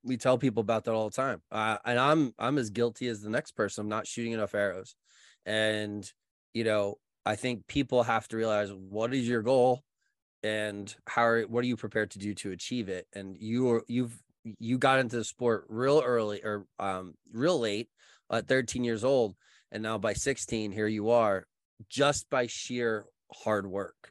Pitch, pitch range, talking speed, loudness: 115 Hz, 105-125 Hz, 200 wpm, -30 LUFS